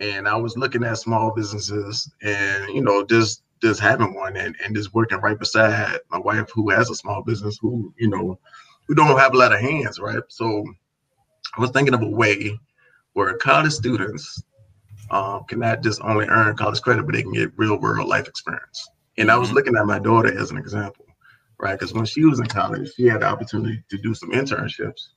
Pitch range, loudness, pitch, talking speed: 105-115 Hz, -20 LUFS, 110 Hz, 210 wpm